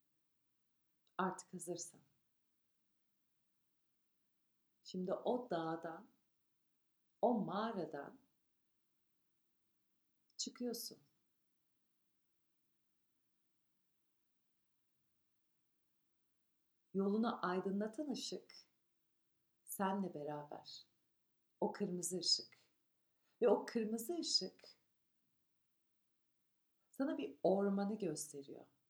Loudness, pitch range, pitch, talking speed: -41 LUFS, 165-225 Hz, 190 Hz, 50 wpm